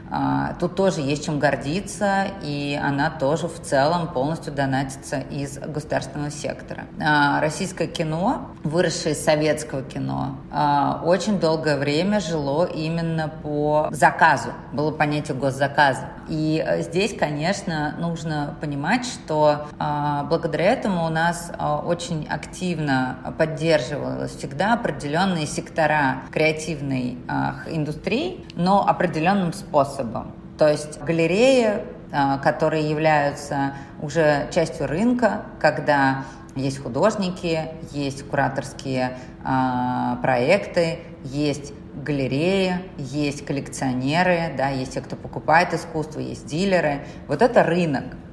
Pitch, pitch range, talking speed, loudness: 155 Hz, 140-170 Hz, 100 wpm, -22 LUFS